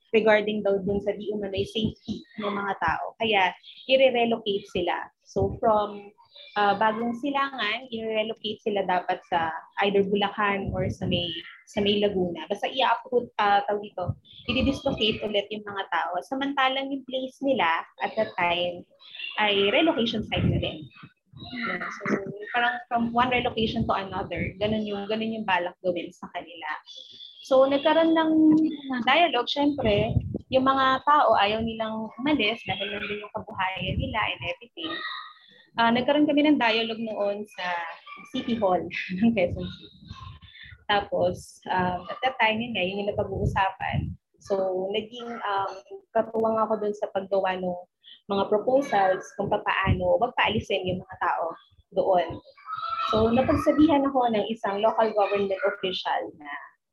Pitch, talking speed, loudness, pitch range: 215 Hz, 145 wpm, -25 LUFS, 195-245 Hz